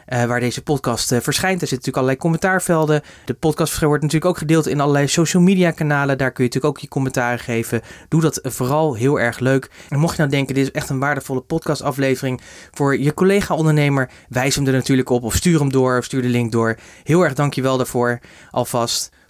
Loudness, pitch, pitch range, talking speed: -18 LUFS, 140 Hz, 125-155 Hz, 215 wpm